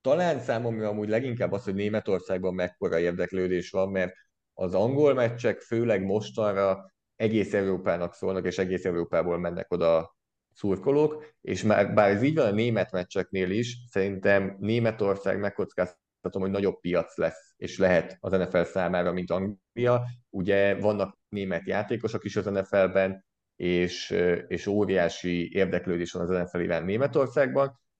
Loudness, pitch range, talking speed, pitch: -27 LUFS, 90-110 Hz, 140 wpm, 100 Hz